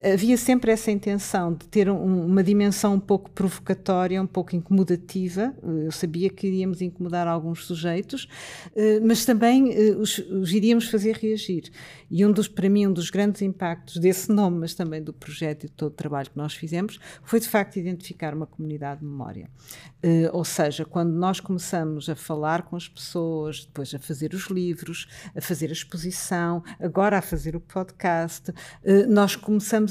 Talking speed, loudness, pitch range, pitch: 170 wpm, -24 LUFS, 160-200 Hz, 180 Hz